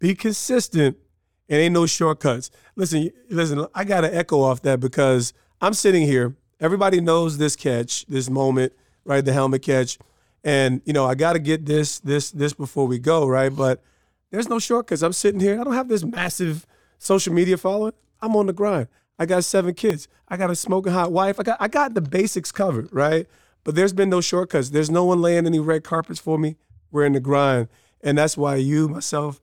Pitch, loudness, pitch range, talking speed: 160 Hz, -21 LUFS, 140-185 Hz, 210 wpm